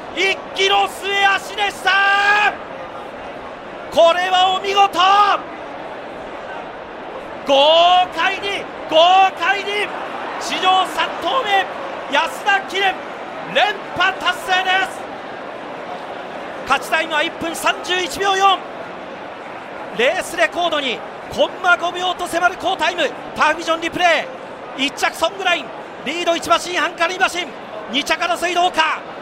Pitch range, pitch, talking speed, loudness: 330-385 Hz, 355 Hz, 200 characters per minute, -17 LUFS